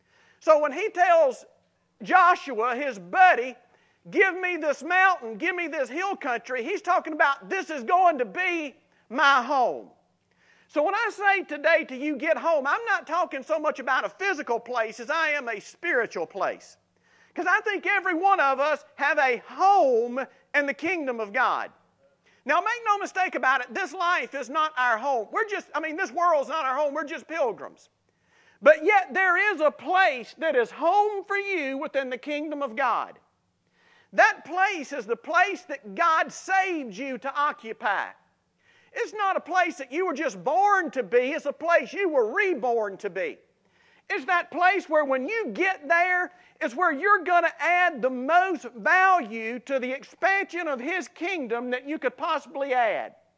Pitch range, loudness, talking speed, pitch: 275-370 Hz, -24 LUFS, 185 wpm, 320 Hz